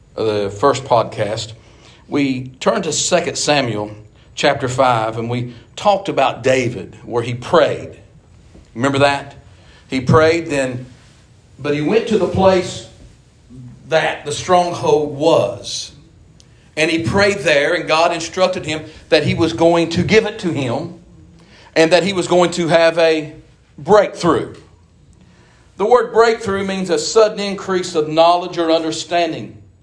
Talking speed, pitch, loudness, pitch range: 140 wpm, 155 Hz, -16 LUFS, 120-175 Hz